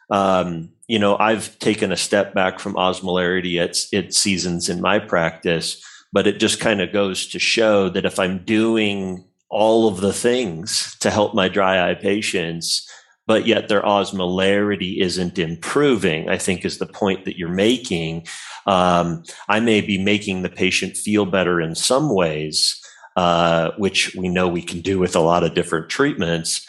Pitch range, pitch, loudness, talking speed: 85-100 Hz, 95 Hz, -19 LUFS, 175 wpm